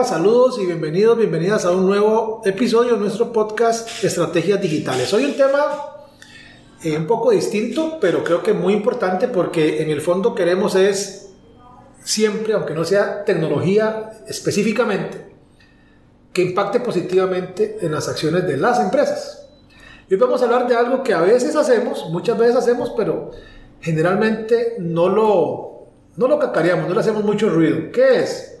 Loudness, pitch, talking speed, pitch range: -18 LUFS, 220 Hz, 155 wpm, 185-255 Hz